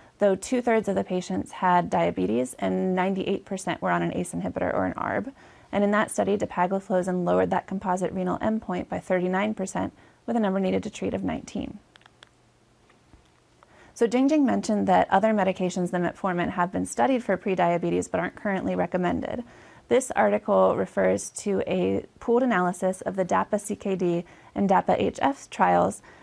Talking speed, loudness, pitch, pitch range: 160 wpm, -25 LUFS, 185 Hz, 175-205 Hz